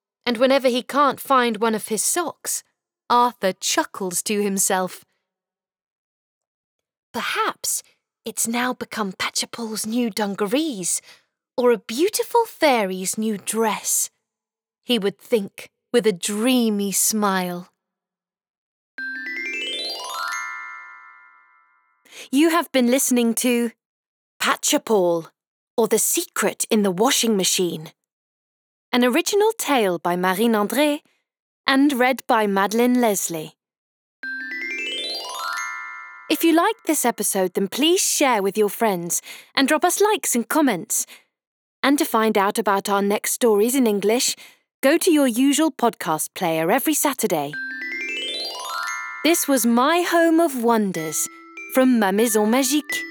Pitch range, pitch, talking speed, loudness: 190-275 Hz, 225 Hz, 115 wpm, -20 LUFS